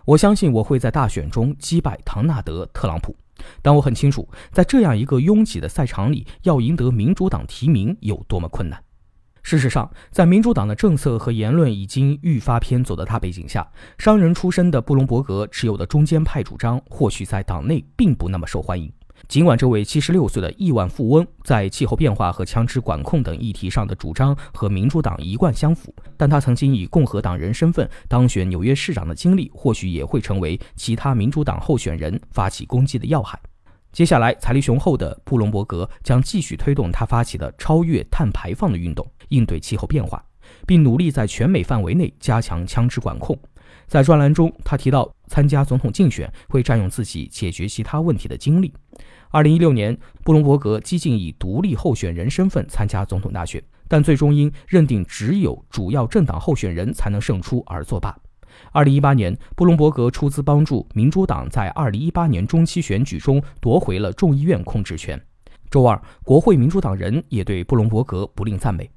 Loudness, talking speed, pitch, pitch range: -19 LUFS, 300 characters per minute, 125 Hz, 100-150 Hz